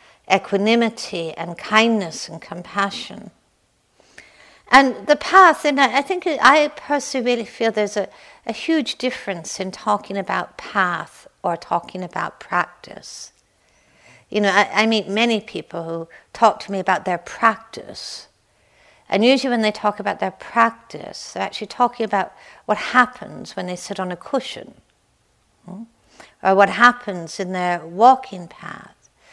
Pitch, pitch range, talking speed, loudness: 210 Hz, 190-245 Hz, 140 wpm, -19 LUFS